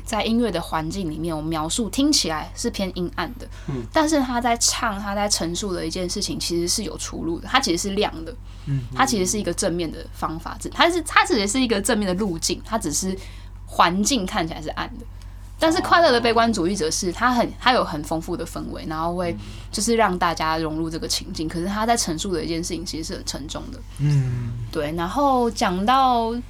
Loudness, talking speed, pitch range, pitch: -22 LUFS, 315 characters per minute, 160-230 Hz, 180 Hz